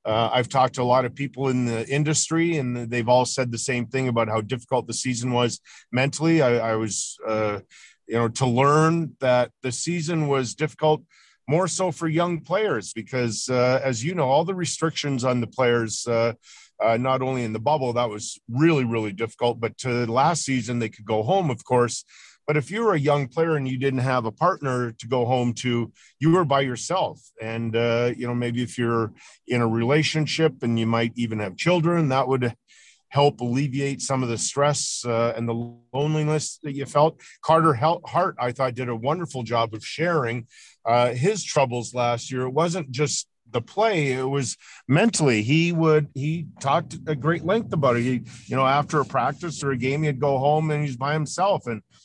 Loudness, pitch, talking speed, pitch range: -23 LUFS, 130 Hz, 205 wpm, 120-150 Hz